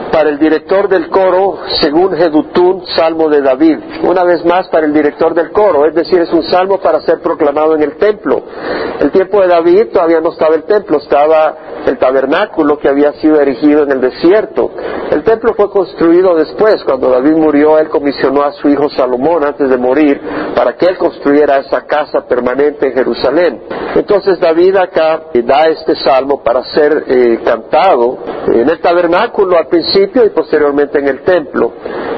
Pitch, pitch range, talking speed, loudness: 165 Hz, 150-190 Hz, 175 wpm, -10 LUFS